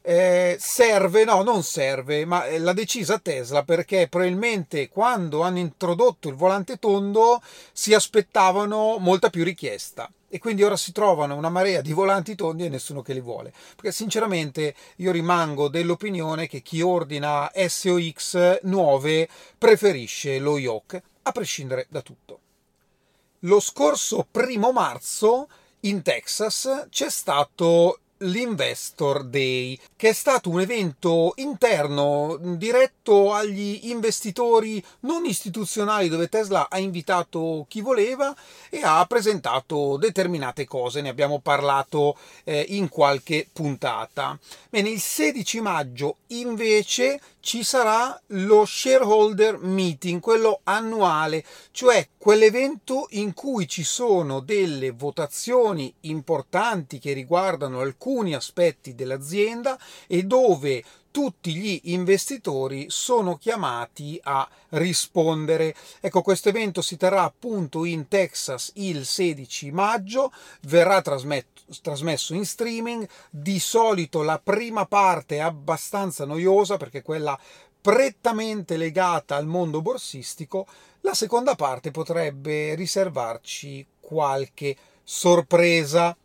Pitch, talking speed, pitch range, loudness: 180 Hz, 115 wpm, 155-215 Hz, -23 LUFS